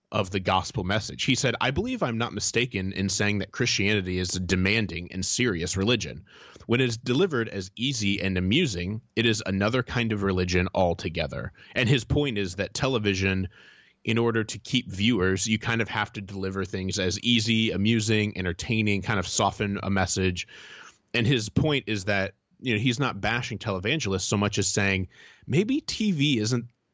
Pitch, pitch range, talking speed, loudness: 105 Hz, 95-120 Hz, 180 wpm, -26 LUFS